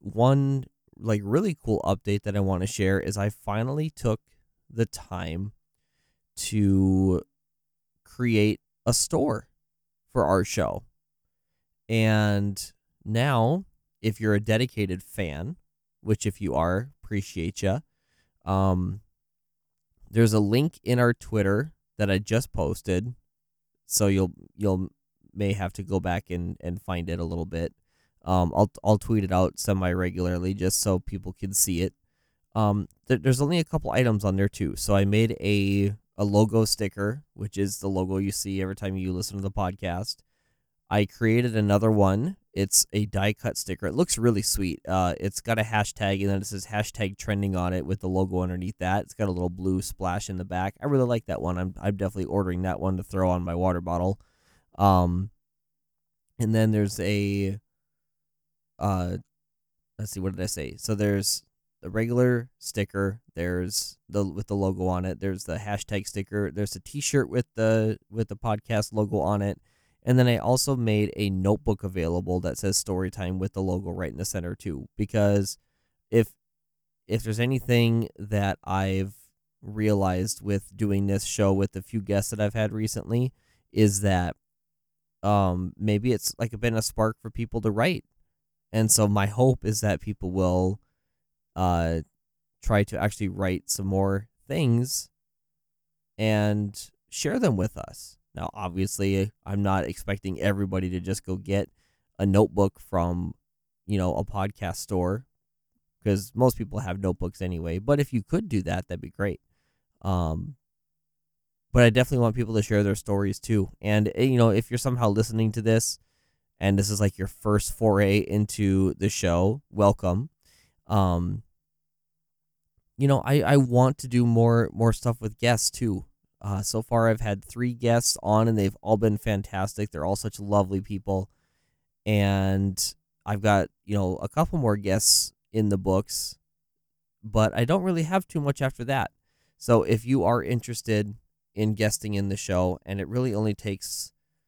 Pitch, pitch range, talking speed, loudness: 100 Hz, 95-110 Hz, 170 wpm, -26 LUFS